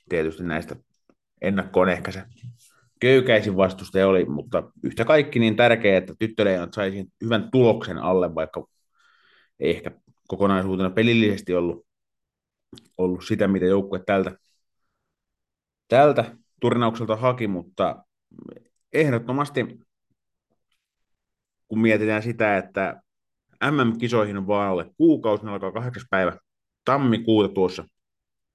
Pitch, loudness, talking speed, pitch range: 105 Hz, -22 LUFS, 105 wpm, 95-115 Hz